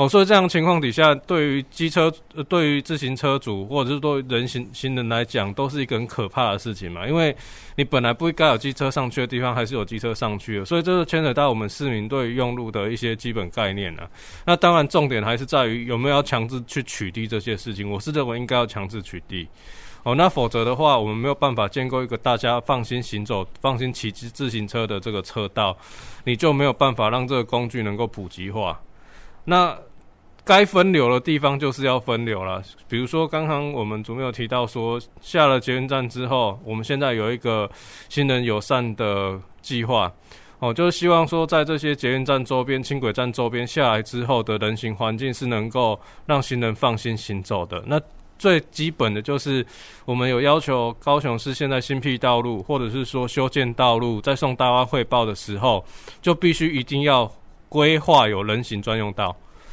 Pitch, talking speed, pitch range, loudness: 125 Hz, 310 characters per minute, 115-140 Hz, -22 LUFS